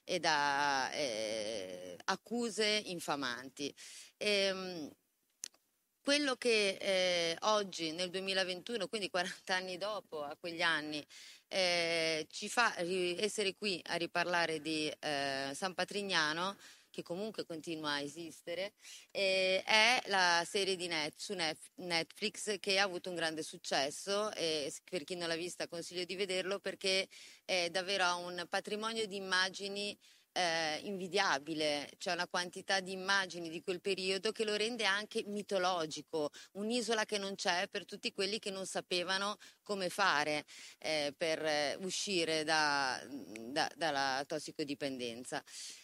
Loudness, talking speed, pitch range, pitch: -36 LUFS, 130 wpm, 160-200 Hz, 180 Hz